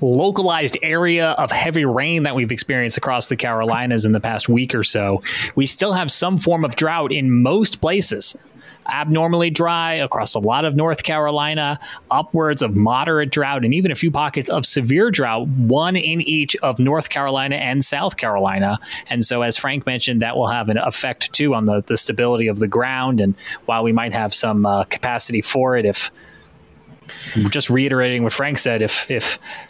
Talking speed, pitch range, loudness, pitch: 185 wpm, 115-150 Hz, -18 LUFS, 130 Hz